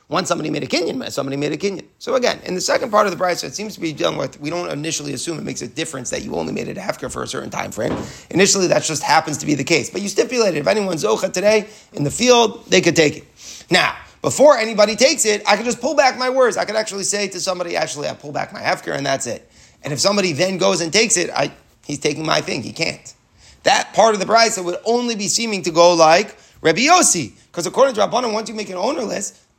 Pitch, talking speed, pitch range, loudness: 190 Hz, 265 wpm, 160-220 Hz, -18 LUFS